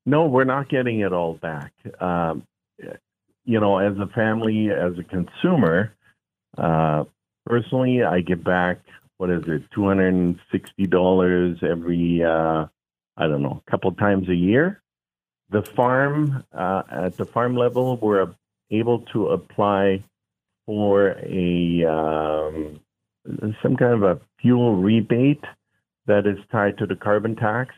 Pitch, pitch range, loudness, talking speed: 100 Hz, 85-115 Hz, -21 LUFS, 135 wpm